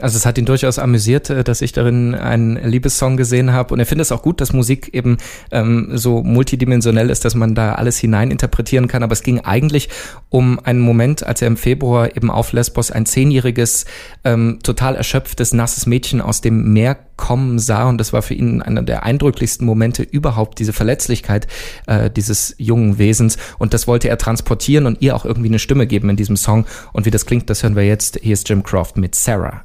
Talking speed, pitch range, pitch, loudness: 210 wpm, 110-125 Hz, 120 Hz, -15 LUFS